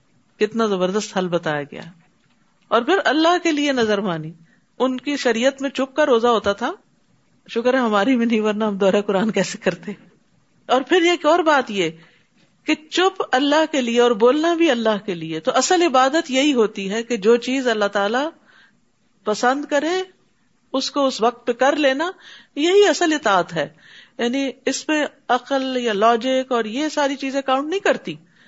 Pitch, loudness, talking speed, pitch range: 250 Hz, -19 LUFS, 180 wpm, 210-285 Hz